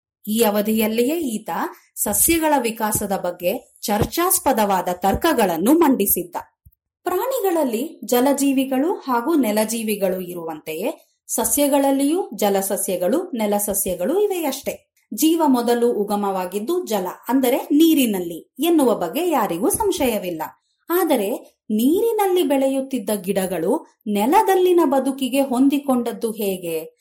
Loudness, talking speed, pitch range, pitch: -20 LUFS, 80 wpm, 205-305 Hz, 255 Hz